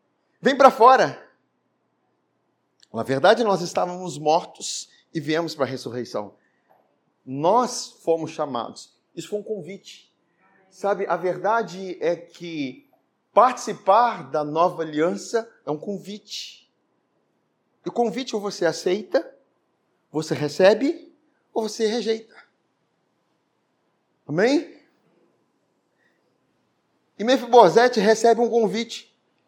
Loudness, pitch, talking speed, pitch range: -22 LUFS, 195 Hz, 100 wpm, 165-230 Hz